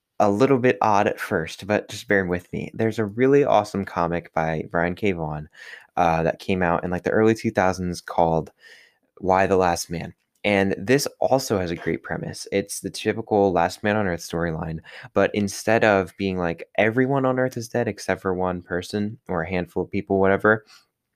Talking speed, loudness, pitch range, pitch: 195 wpm, -23 LUFS, 85-110 Hz, 95 Hz